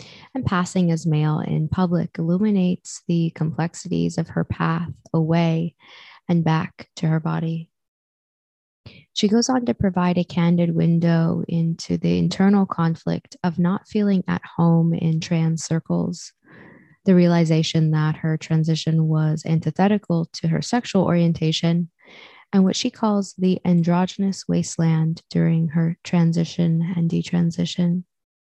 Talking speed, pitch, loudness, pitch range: 130 wpm, 170 Hz, -21 LUFS, 160-180 Hz